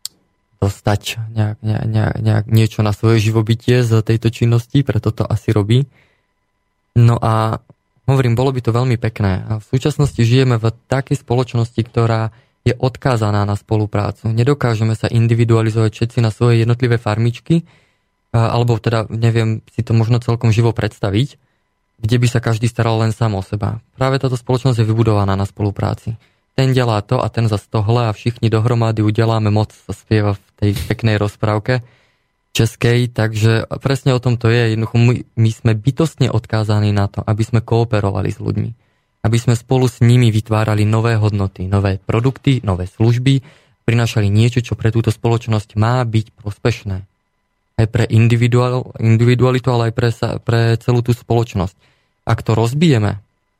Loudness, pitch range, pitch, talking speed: -16 LUFS, 110-120 Hz, 115 Hz, 155 wpm